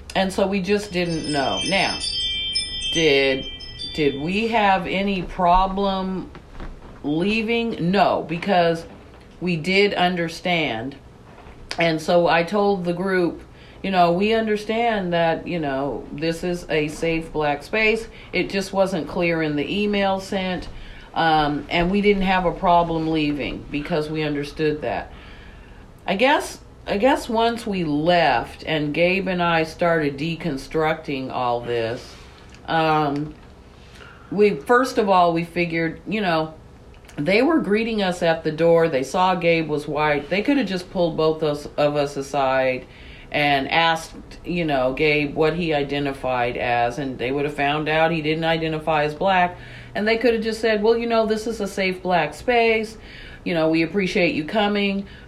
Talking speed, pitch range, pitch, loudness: 155 wpm, 145-190 Hz, 165 Hz, -21 LUFS